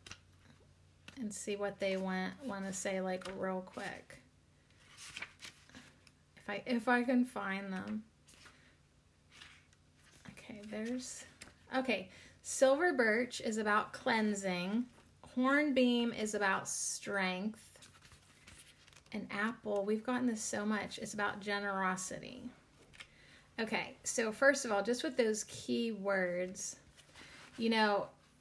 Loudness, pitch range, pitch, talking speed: -36 LUFS, 195-245 Hz, 210 Hz, 110 wpm